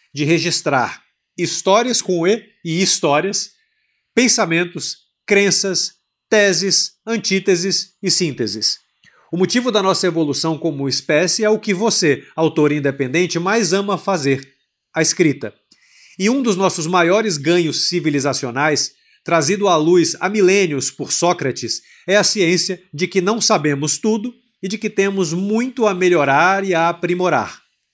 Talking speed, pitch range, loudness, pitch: 135 wpm, 160-200 Hz, -17 LUFS, 180 Hz